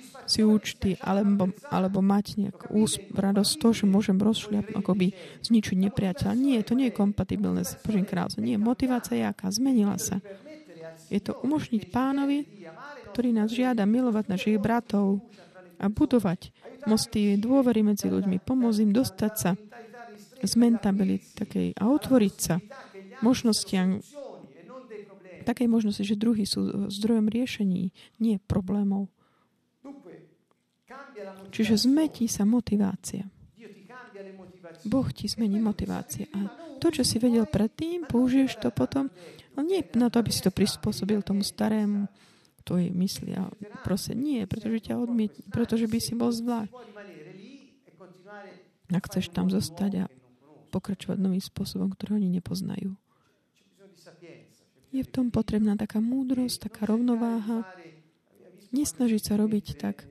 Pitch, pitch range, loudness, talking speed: 210 Hz, 190-235 Hz, -27 LUFS, 130 wpm